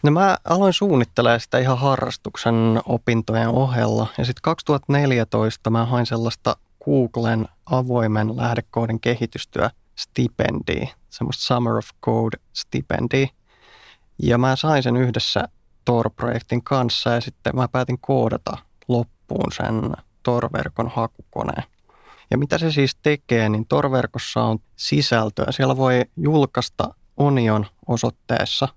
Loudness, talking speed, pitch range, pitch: -21 LUFS, 115 wpm, 115-130 Hz, 120 Hz